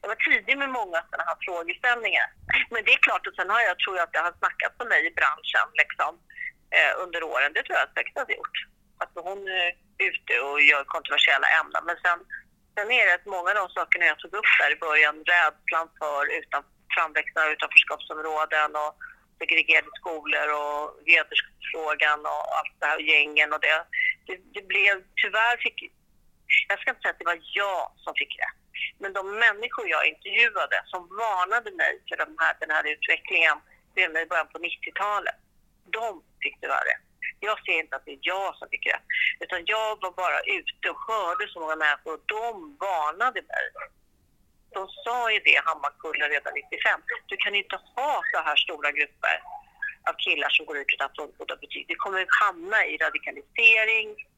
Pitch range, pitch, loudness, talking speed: 160-250 Hz, 195 Hz, -24 LUFS, 190 wpm